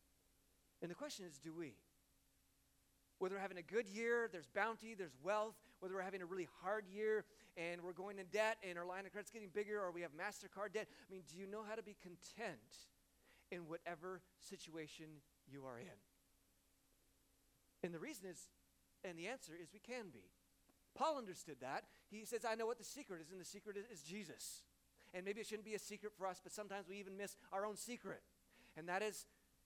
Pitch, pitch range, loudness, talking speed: 195 Hz, 175-215 Hz, -48 LUFS, 210 wpm